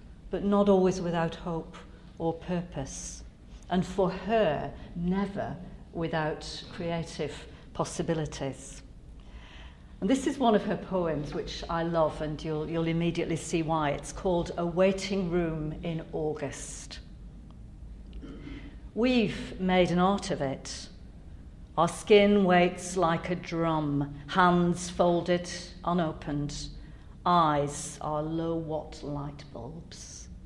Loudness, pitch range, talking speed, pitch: -29 LUFS, 150-180 Hz, 115 wpm, 165 Hz